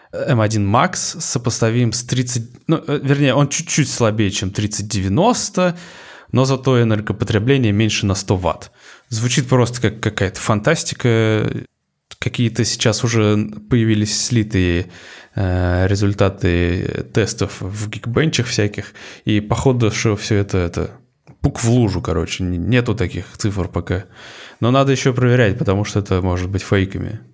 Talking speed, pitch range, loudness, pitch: 130 wpm, 100-125 Hz, -18 LUFS, 110 Hz